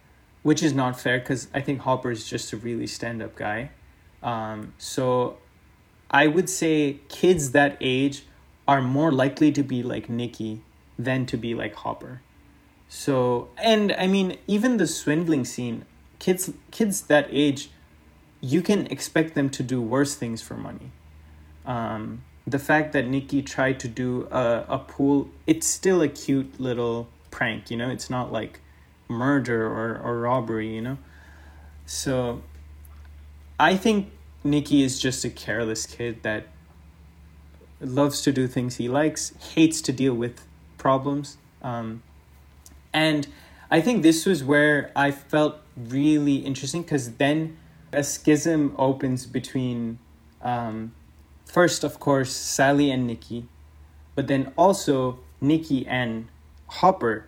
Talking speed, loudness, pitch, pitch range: 140 wpm, -24 LUFS, 130 Hz, 110-145 Hz